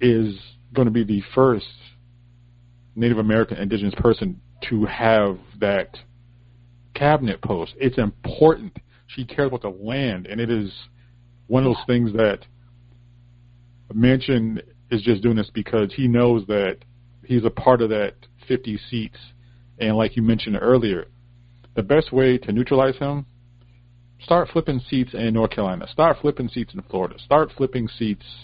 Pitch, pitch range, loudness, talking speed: 120 Hz, 115-125 Hz, -21 LUFS, 150 wpm